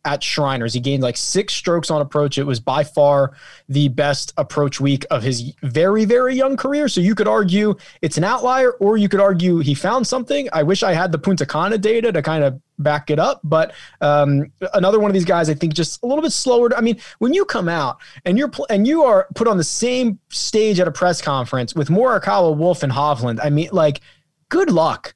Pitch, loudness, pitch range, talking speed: 170 Hz, -17 LUFS, 145-215 Hz, 230 wpm